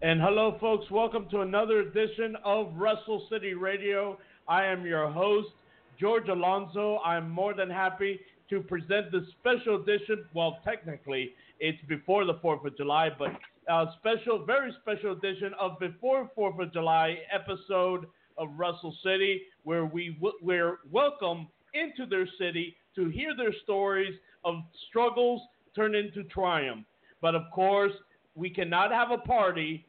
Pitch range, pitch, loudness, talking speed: 170-210 Hz, 195 Hz, -30 LUFS, 150 wpm